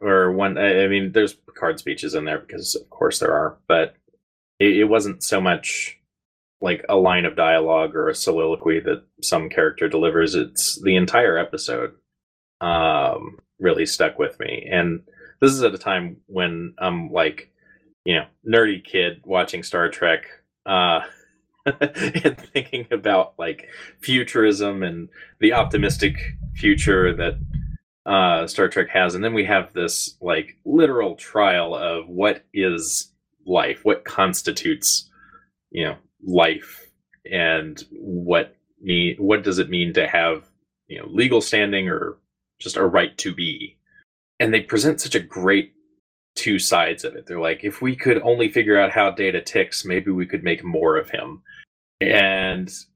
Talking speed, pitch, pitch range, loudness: 155 wpm, 95 Hz, 90-115 Hz, -20 LUFS